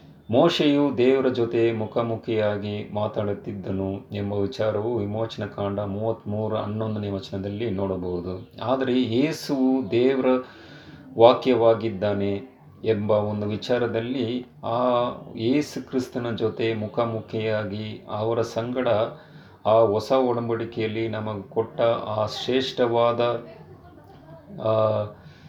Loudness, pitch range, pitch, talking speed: -24 LUFS, 105-125 Hz, 115 Hz, 80 wpm